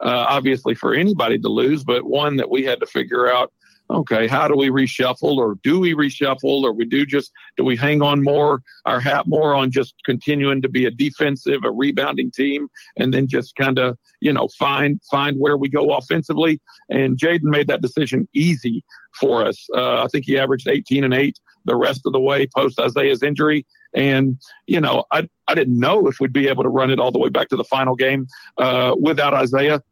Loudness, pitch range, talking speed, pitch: -18 LUFS, 130-145 Hz, 215 wpm, 135 Hz